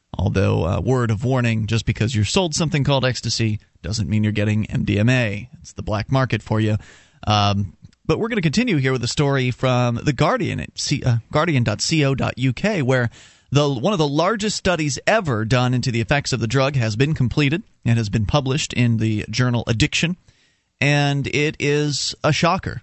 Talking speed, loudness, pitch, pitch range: 185 wpm, -20 LUFS, 125 Hz, 110-145 Hz